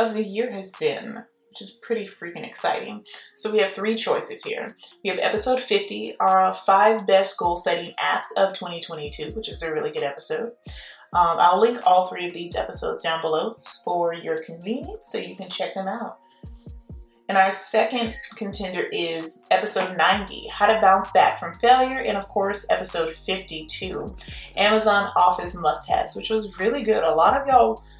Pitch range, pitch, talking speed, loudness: 180-230 Hz, 200 Hz, 180 wpm, -23 LUFS